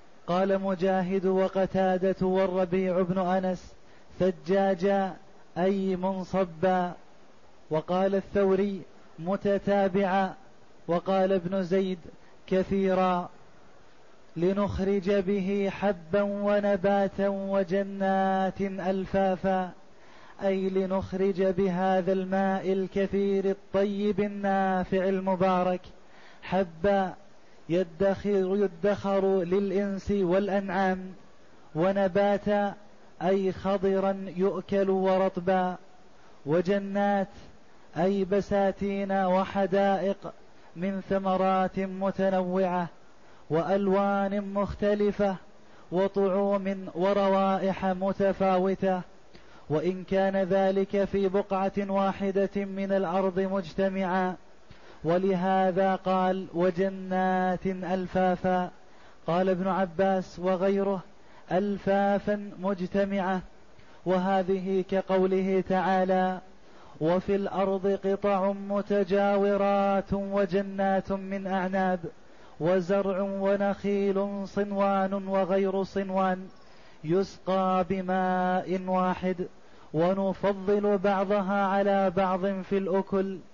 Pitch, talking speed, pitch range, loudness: 195 Hz, 70 wpm, 185-195 Hz, -27 LUFS